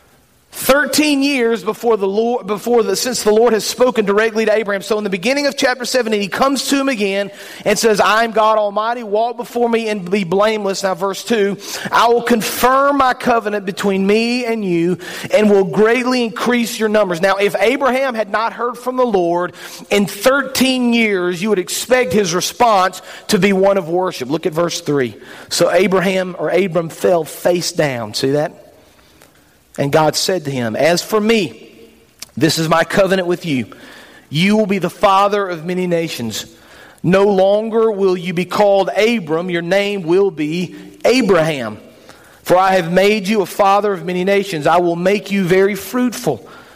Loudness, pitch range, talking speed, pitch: -15 LUFS, 180-230 Hz, 180 wpm, 200 Hz